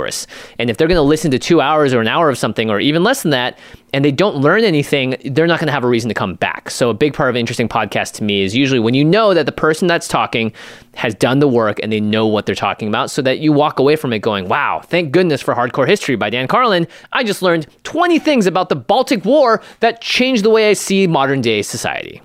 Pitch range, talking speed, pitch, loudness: 120-180 Hz, 270 wpm, 145 Hz, -15 LUFS